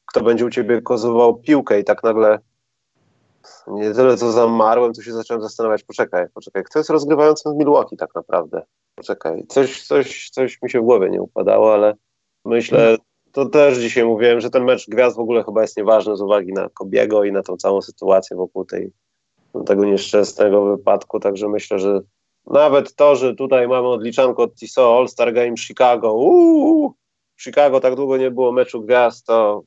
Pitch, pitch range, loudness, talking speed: 120 Hz, 105-130 Hz, -16 LUFS, 180 wpm